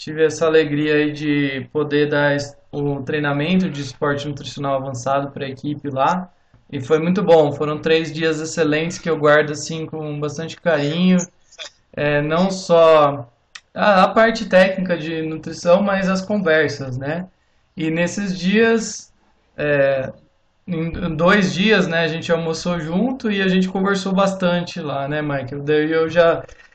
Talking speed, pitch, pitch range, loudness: 155 wpm, 160 Hz, 145-175 Hz, -18 LUFS